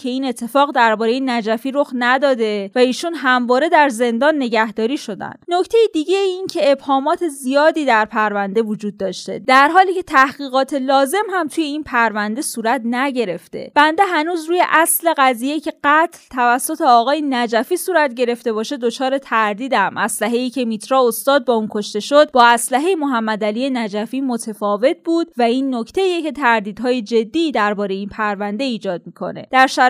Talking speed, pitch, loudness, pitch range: 155 wpm, 255 Hz, -17 LUFS, 225-295 Hz